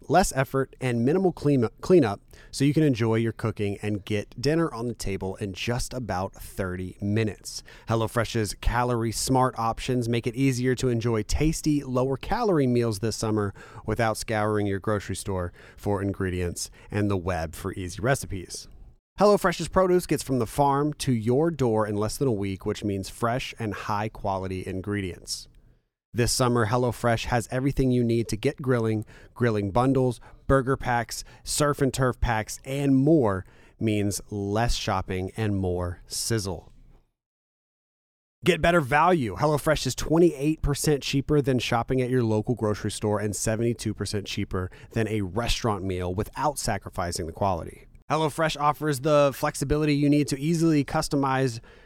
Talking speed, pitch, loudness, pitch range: 155 wpm, 115 Hz, -26 LUFS, 105-135 Hz